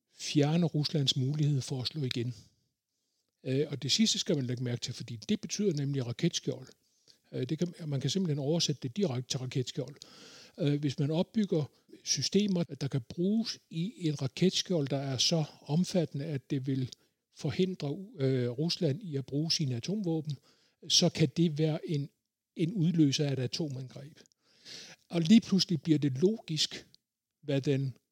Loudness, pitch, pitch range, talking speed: -31 LUFS, 150 Hz, 135-170 Hz, 145 wpm